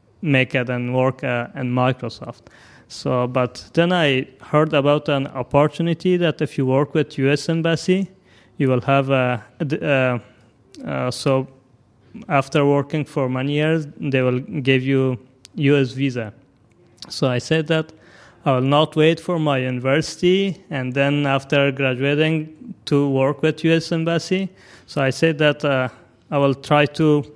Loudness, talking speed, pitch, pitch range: -20 LUFS, 150 wpm, 140 Hz, 130-155 Hz